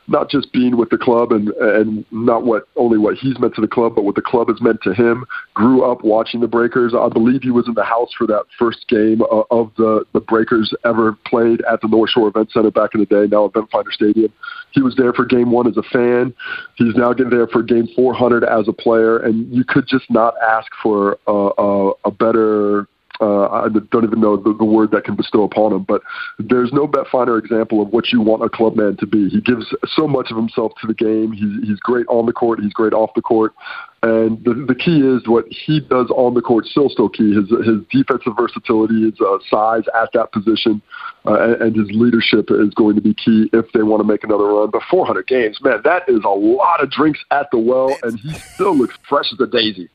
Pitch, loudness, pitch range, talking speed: 115 Hz, -15 LUFS, 110-125 Hz, 240 wpm